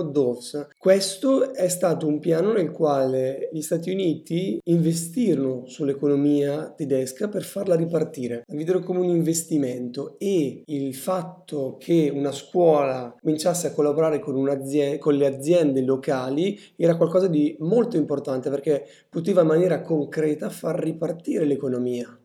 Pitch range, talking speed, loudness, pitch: 140-170 Hz, 130 wpm, -23 LUFS, 155 Hz